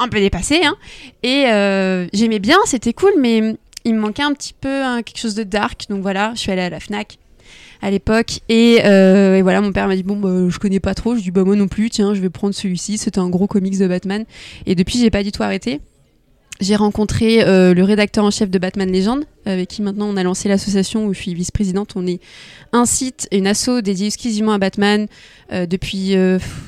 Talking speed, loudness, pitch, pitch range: 235 wpm, -16 LUFS, 205 Hz, 190-225 Hz